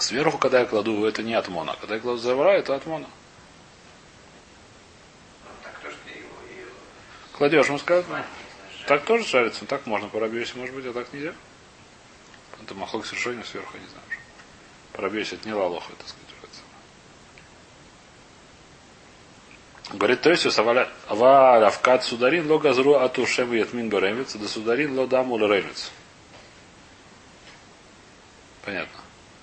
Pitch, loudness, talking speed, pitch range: 125 Hz, -22 LUFS, 105 wpm, 120-145 Hz